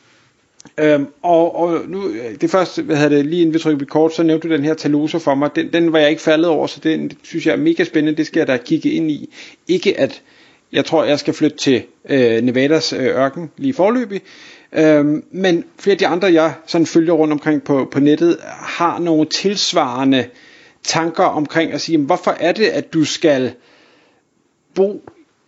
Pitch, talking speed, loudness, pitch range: 160 Hz, 200 wpm, -16 LUFS, 150-175 Hz